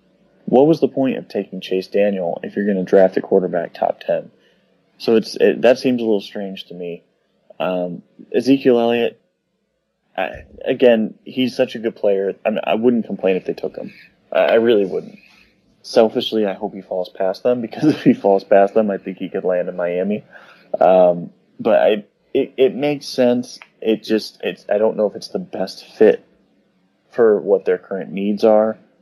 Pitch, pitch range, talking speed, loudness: 105 Hz, 95-125 Hz, 195 wpm, -18 LUFS